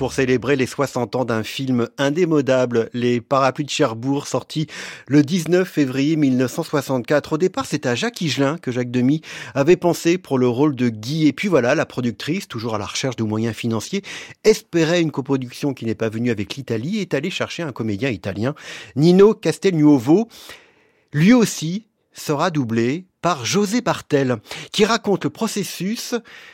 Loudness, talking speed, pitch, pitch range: -20 LUFS, 165 wpm, 145 Hz, 125-175 Hz